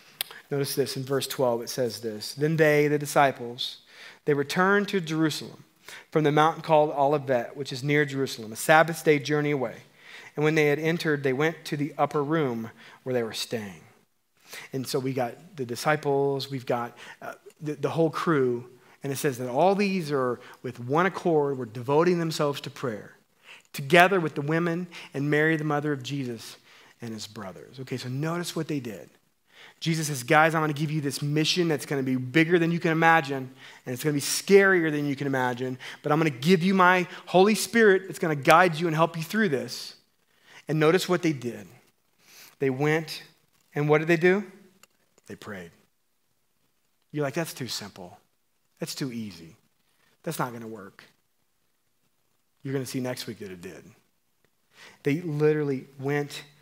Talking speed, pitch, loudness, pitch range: 190 wpm, 150 Hz, -25 LUFS, 130-160 Hz